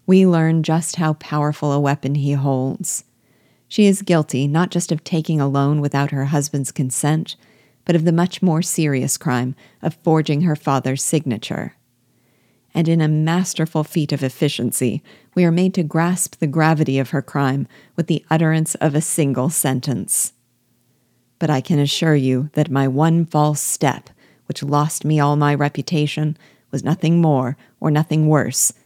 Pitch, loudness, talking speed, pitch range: 150 Hz, -19 LUFS, 165 wpm, 135-160 Hz